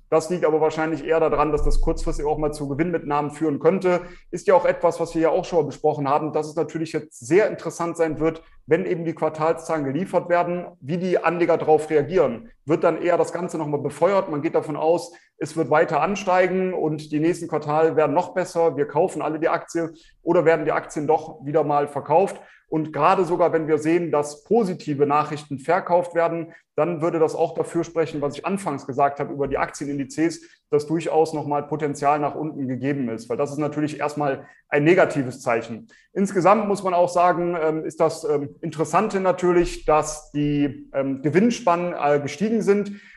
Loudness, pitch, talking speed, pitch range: -22 LUFS, 160 Hz, 190 wpm, 150-170 Hz